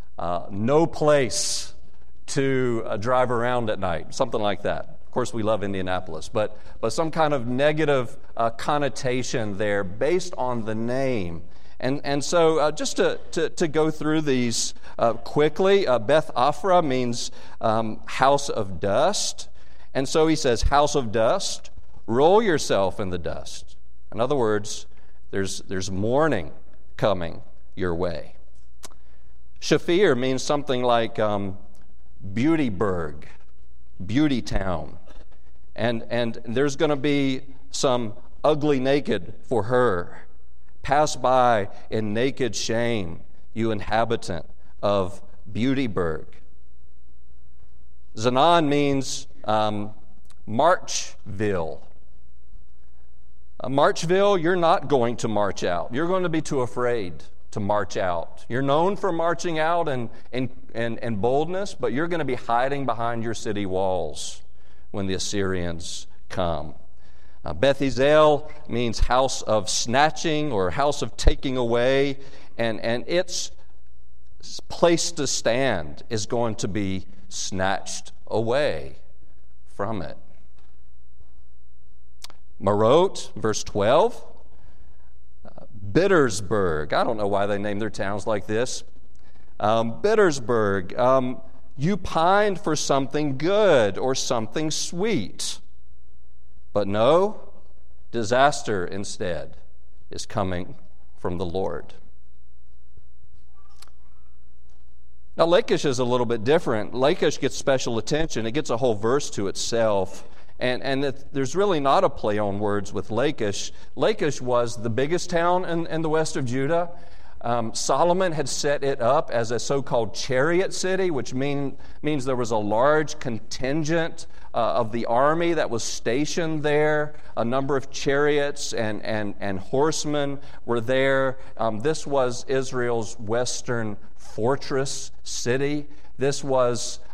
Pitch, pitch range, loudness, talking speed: 115 Hz, 85-140 Hz, -24 LUFS, 125 wpm